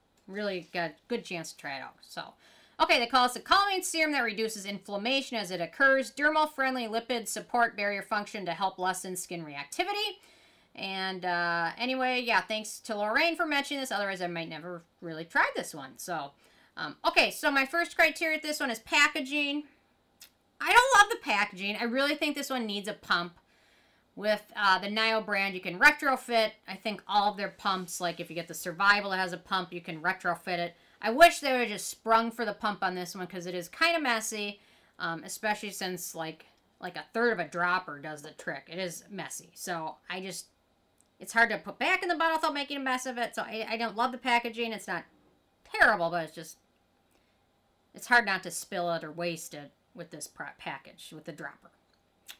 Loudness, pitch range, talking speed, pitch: -29 LUFS, 180-260 Hz, 210 wpm, 210 Hz